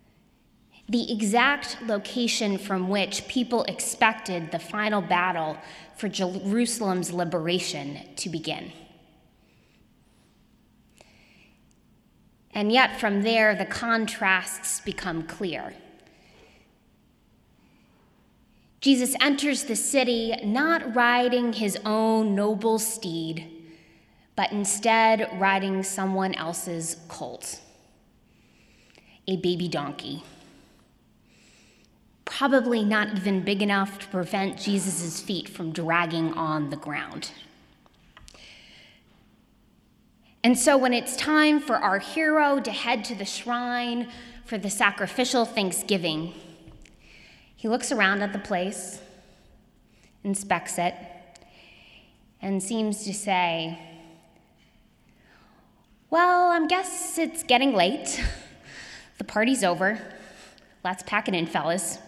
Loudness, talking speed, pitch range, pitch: -25 LUFS, 95 wpm, 180-235 Hz, 200 Hz